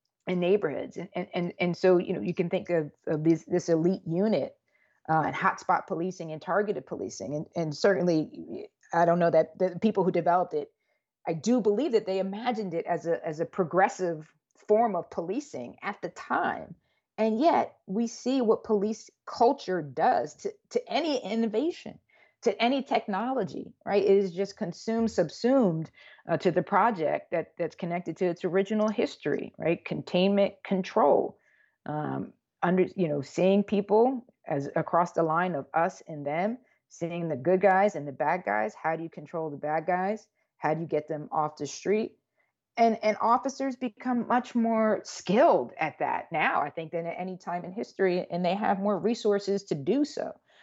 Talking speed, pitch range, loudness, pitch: 180 wpm, 170-220 Hz, -28 LUFS, 185 Hz